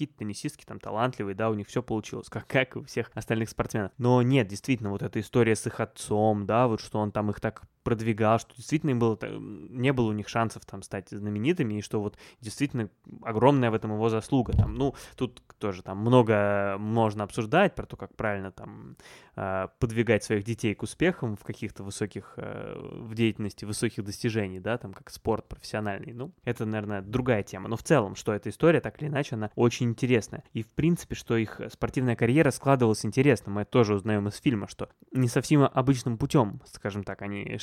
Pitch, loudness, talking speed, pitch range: 115 Hz, -28 LUFS, 195 wpm, 105-125 Hz